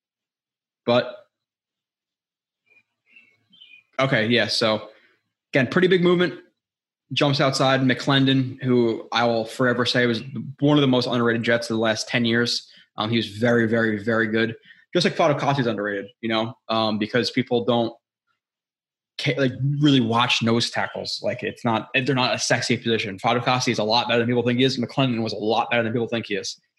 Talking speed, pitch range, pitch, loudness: 175 wpm, 115-130 Hz, 120 Hz, -22 LUFS